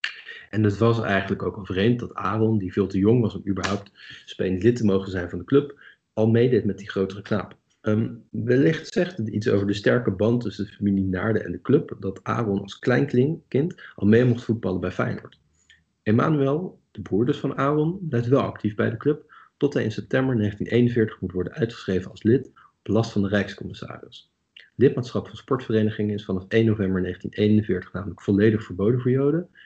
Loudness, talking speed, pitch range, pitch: -24 LUFS, 195 wpm, 100-125 Hz, 110 Hz